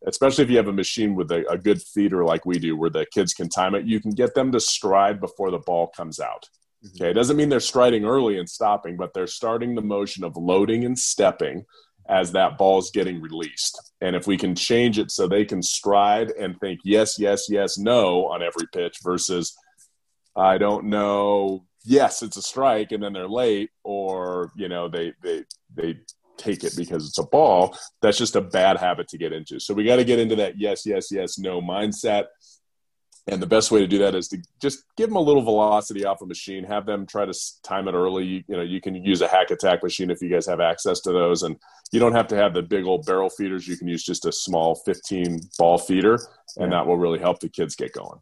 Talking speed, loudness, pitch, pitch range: 235 wpm, -22 LUFS, 100 Hz, 90-105 Hz